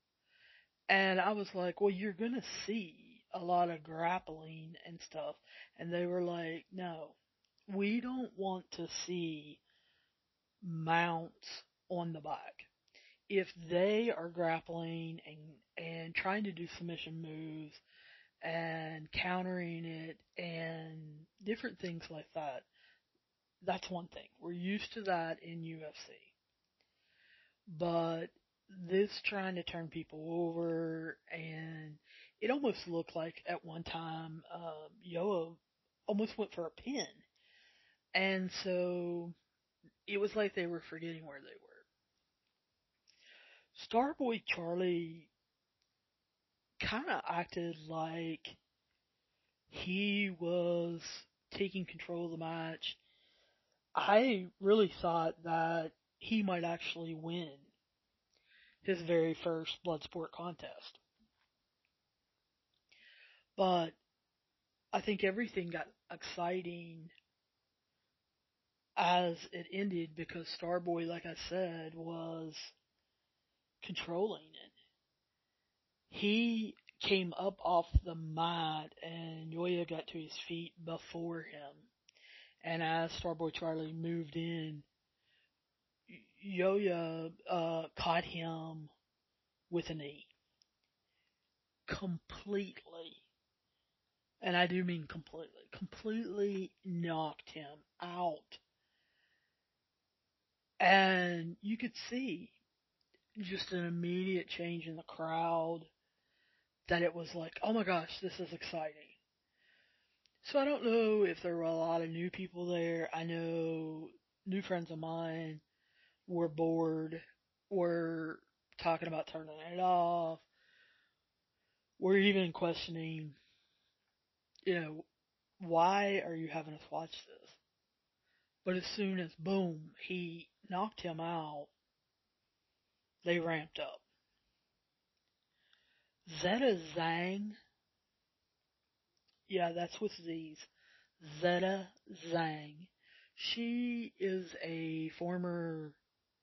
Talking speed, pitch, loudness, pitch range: 105 wpm, 170 Hz, -38 LUFS, 165-185 Hz